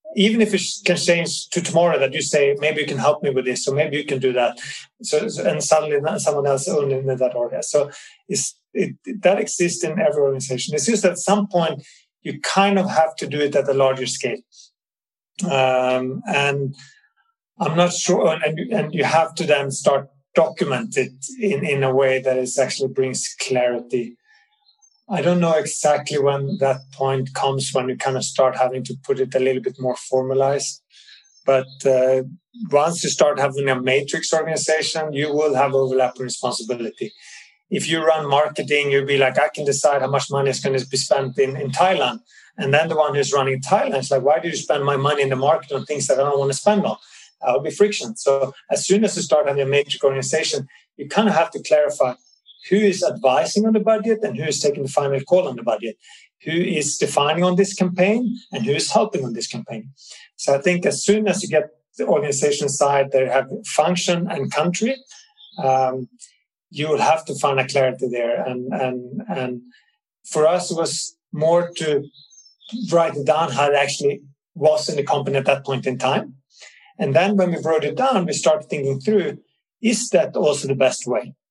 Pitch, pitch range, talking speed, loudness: 150 Hz, 135-190 Hz, 205 wpm, -20 LUFS